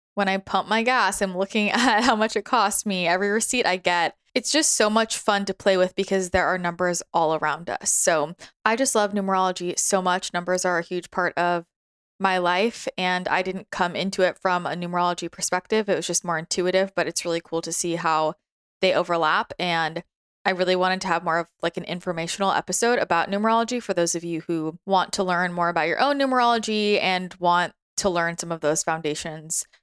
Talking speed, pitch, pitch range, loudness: 215 wpm, 185 Hz, 170-200 Hz, -23 LUFS